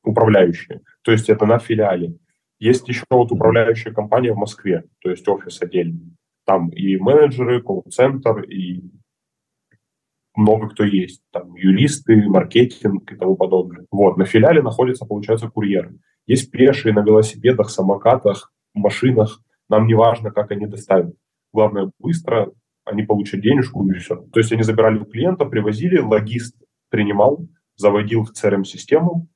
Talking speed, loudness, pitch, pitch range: 140 wpm, -17 LUFS, 110 Hz, 100-125 Hz